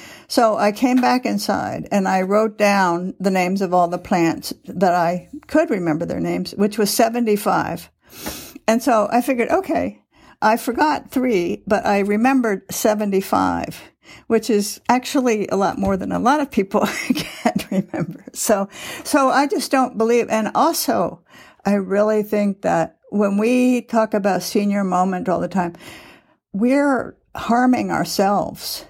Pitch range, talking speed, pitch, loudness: 195-250 Hz, 150 wpm, 215 Hz, -19 LUFS